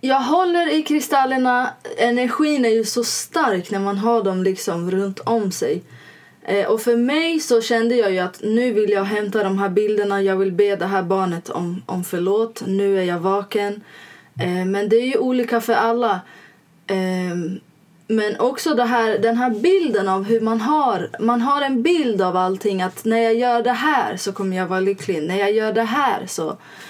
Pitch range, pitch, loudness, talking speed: 195-245 Hz, 220 Hz, -19 LUFS, 200 wpm